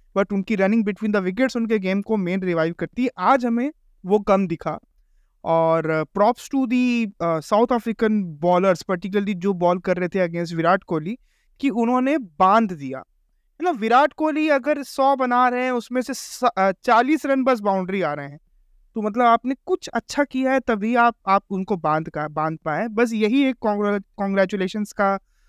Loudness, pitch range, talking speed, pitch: -21 LUFS, 185-250 Hz, 175 wpm, 210 Hz